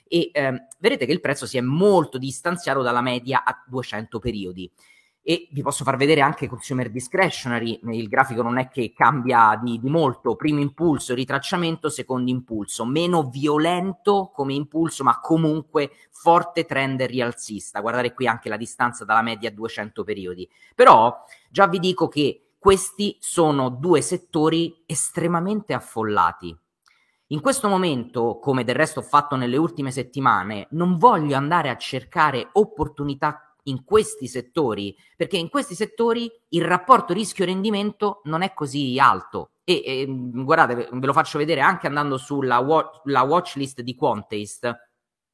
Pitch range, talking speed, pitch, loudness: 125-170 Hz, 150 wpm, 140 Hz, -21 LUFS